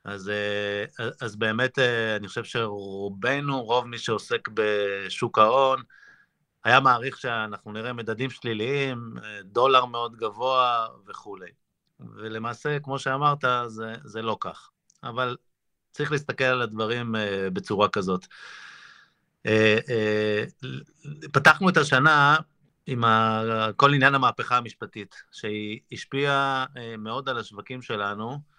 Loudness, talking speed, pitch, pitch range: -24 LUFS, 100 wpm, 120 Hz, 110-130 Hz